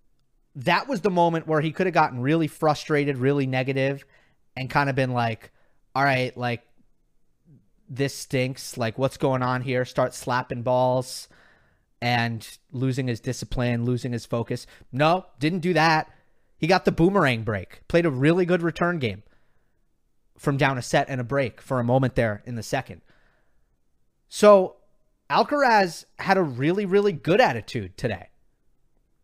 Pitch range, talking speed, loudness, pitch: 120-155 Hz, 155 wpm, -24 LUFS, 130 Hz